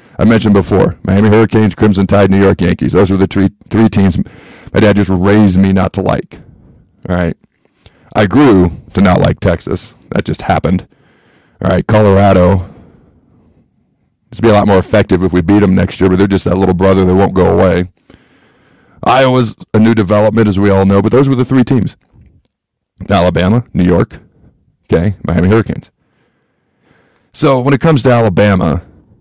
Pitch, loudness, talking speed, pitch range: 100 Hz, -10 LUFS, 175 wpm, 95-110 Hz